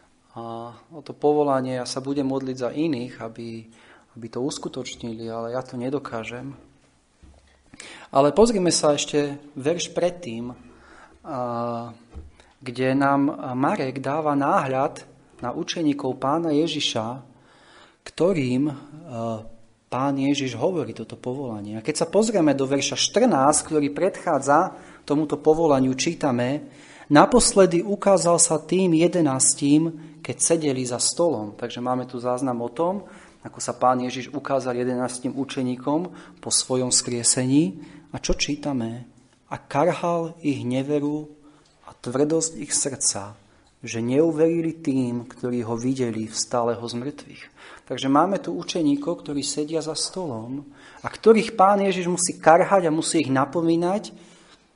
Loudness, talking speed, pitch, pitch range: -22 LUFS, 125 wpm, 140 Hz, 125-160 Hz